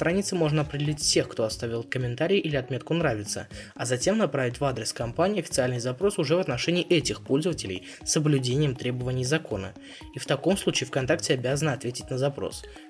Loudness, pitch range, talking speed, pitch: -27 LUFS, 125-160 Hz, 170 wpm, 140 Hz